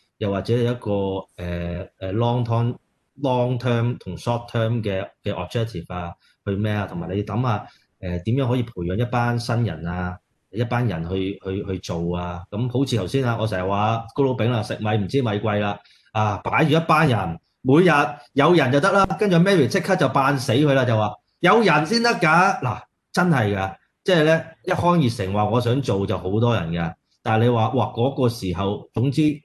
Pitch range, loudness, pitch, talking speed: 100-135 Hz, -21 LUFS, 115 Hz, 330 characters per minute